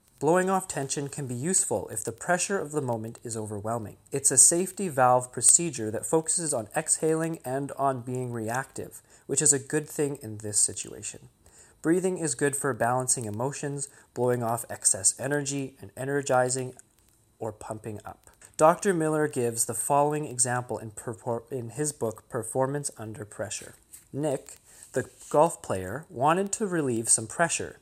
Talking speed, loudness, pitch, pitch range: 155 wpm, -26 LUFS, 130 Hz, 115-150 Hz